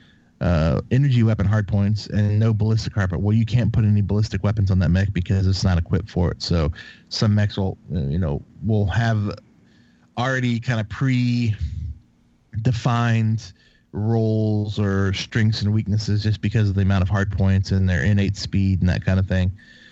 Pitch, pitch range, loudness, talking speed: 105 Hz, 95-110 Hz, -21 LUFS, 180 wpm